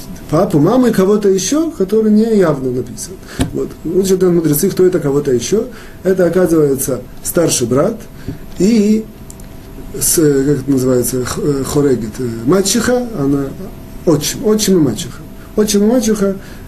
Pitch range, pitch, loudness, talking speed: 135-210 Hz, 175 Hz, -13 LUFS, 130 wpm